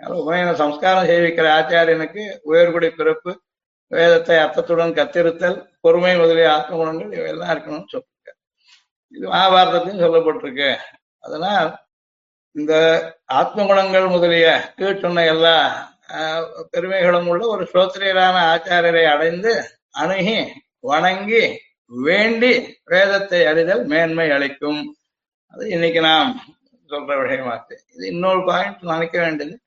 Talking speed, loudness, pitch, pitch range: 100 wpm, -17 LUFS, 170 Hz, 160-185 Hz